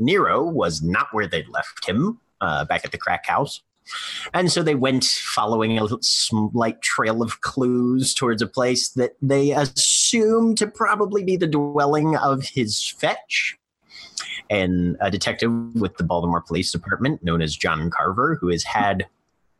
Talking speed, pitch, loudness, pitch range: 160 wpm, 125 Hz, -21 LUFS, 110-155 Hz